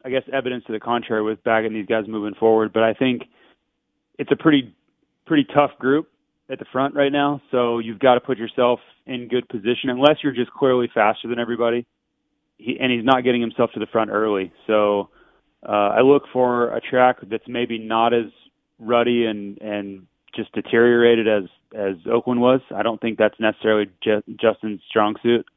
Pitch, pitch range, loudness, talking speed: 120 Hz, 110-125 Hz, -20 LUFS, 190 wpm